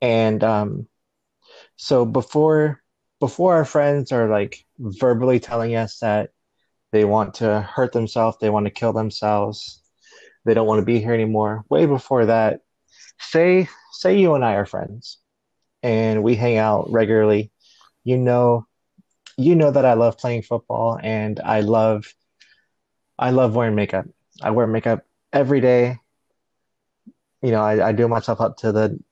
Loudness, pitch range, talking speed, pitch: -19 LUFS, 110-125 Hz, 155 wpm, 115 Hz